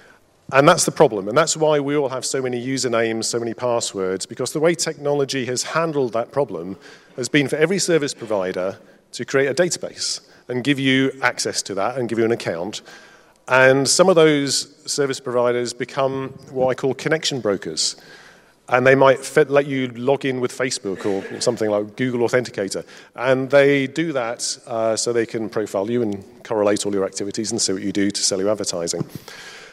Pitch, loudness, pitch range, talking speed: 130 Hz, -20 LUFS, 115-140 Hz, 190 wpm